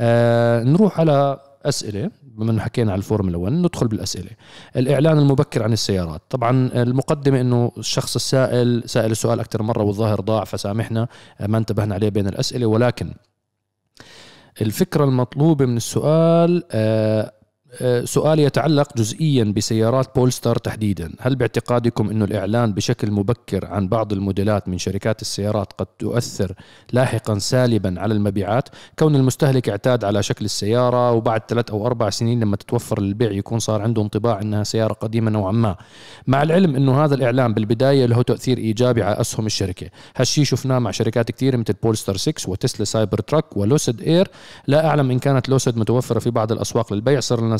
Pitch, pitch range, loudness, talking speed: 115 Hz, 110-130 Hz, -19 LUFS, 155 wpm